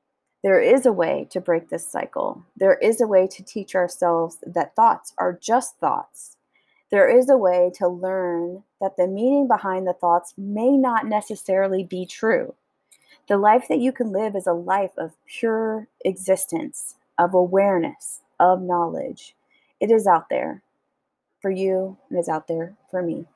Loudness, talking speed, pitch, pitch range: -21 LUFS, 170 wpm, 190 Hz, 180-225 Hz